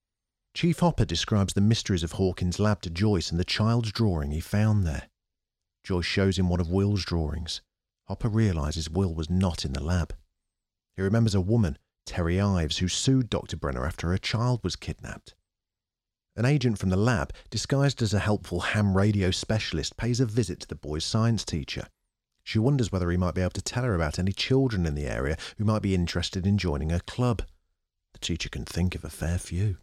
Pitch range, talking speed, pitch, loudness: 85-110 Hz, 200 wpm, 95 Hz, -27 LUFS